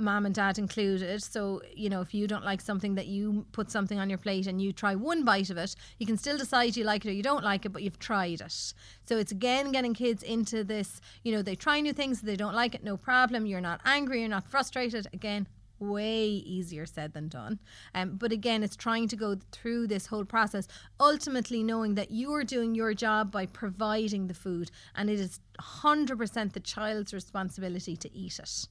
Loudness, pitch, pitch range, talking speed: -31 LUFS, 210 Hz, 195-230 Hz, 225 wpm